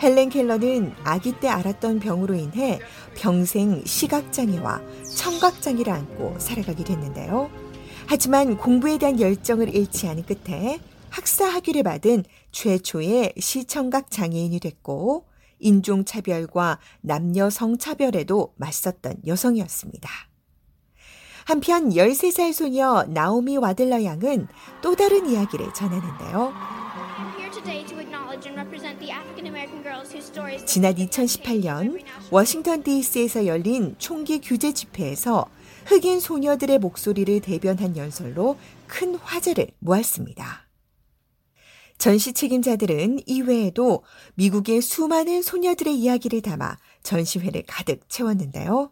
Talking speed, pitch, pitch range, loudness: 250 characters per minute, 230 Hz, 185-275 Hz, -22 LUFS